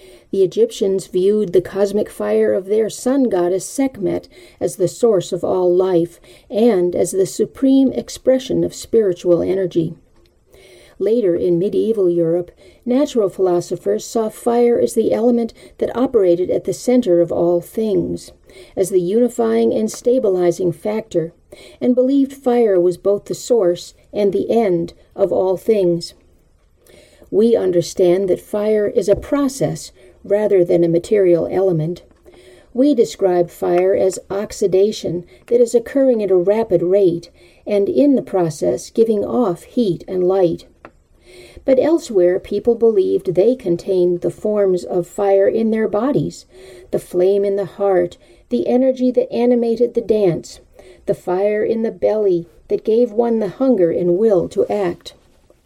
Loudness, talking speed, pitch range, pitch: -17 LUFS, 145 wpm, 175-230 Hz, 195 Hz